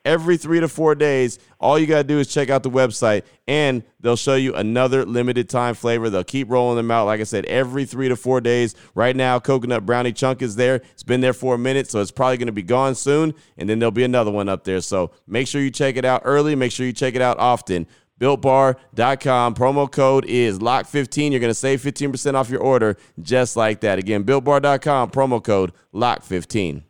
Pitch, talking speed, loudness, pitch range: 130 Hz, 225 wpm, -19 LUFS, 120-135 Hz